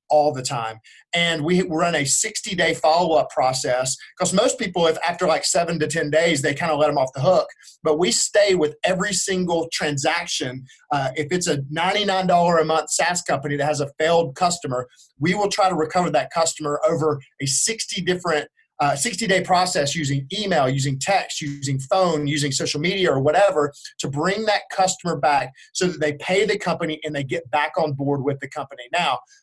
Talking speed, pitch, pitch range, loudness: 195 wpm, 160 Hz, 145-180 Hz, -21 LUFS